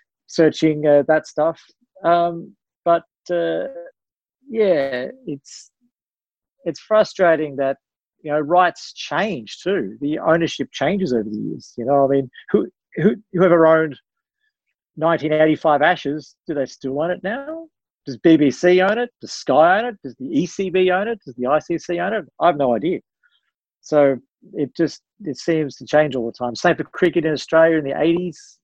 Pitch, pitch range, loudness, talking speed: 160 Hz, 145-185 Hz, -19 LUFS, 170 wpm